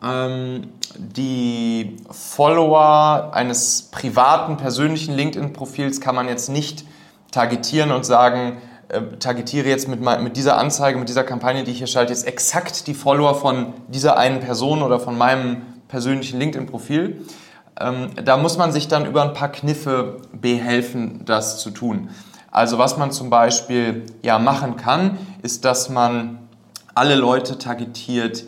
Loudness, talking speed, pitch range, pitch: -19 LUFS, 145 wpm, 120-145 Hz, 130 Hz